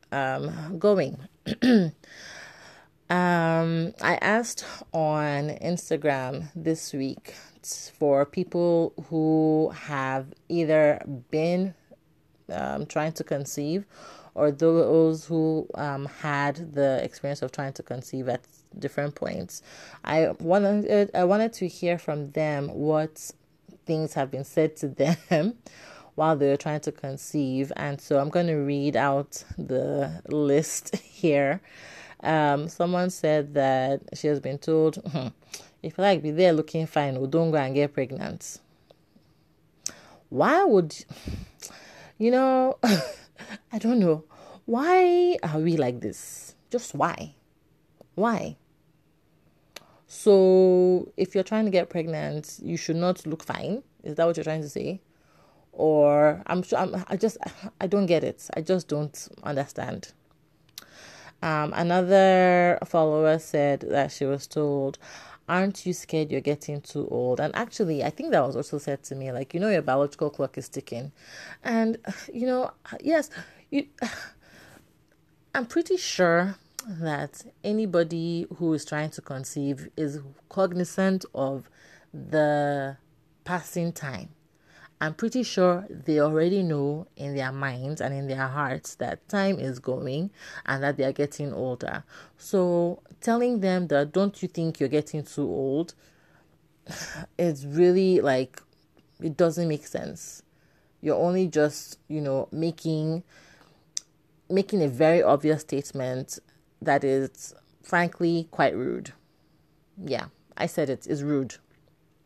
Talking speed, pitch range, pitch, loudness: 135 wpm, 145-180 Hz, 155 Hz, -26 LUFS